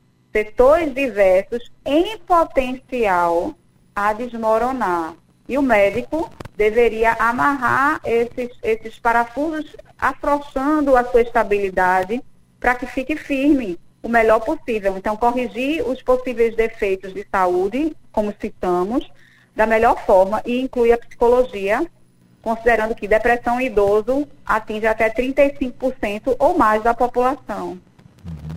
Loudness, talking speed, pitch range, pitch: -19 LUFS, 110 wpm, 215-265 Hz, 235 Hz